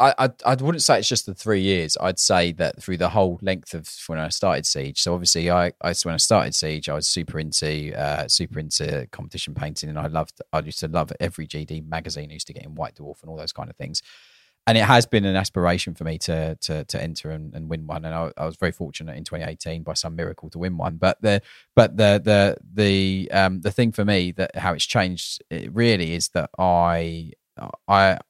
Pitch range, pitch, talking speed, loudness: 80-95 Hz, 85 Hz, 240 wpm, -22 LUFS